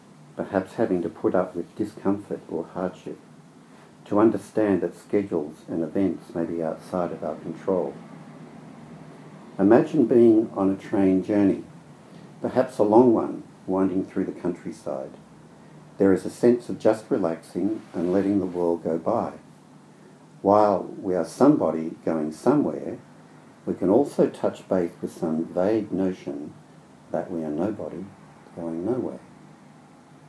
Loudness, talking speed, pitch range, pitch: -24 LUFS, 135 wpm, 85-100 Hz, 90 Hz